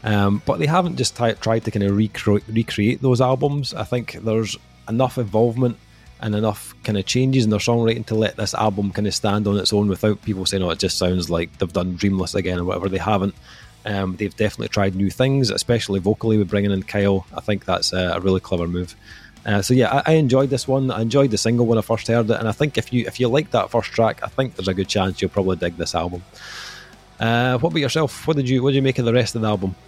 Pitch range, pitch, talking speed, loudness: 95-125 Hz, 110 Hz, 255 wpm, -20 LUFS